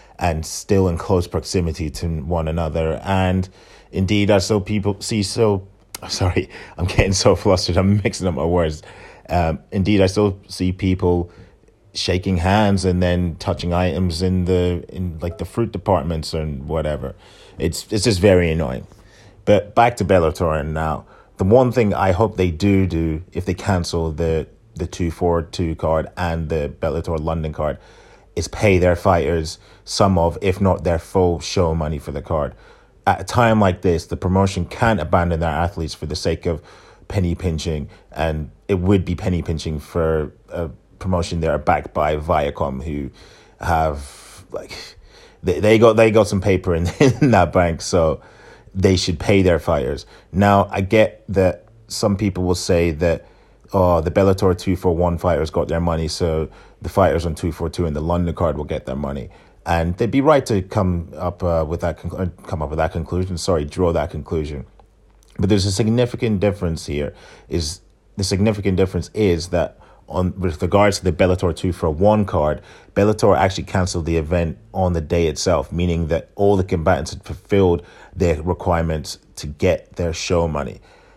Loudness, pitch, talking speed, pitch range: -19 LUFS, 90 Hz, 180 wpm, 80-95 Hz